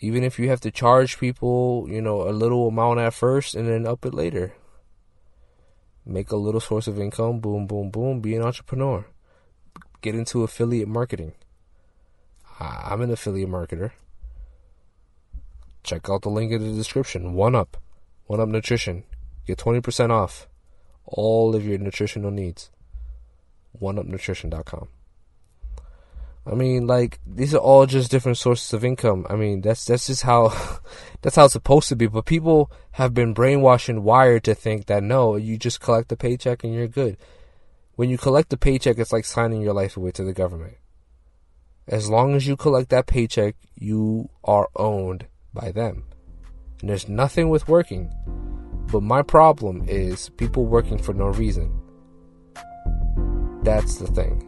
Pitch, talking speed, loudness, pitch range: 110 Hz, 160 wpm, -21 LUFS, 90-120 Hz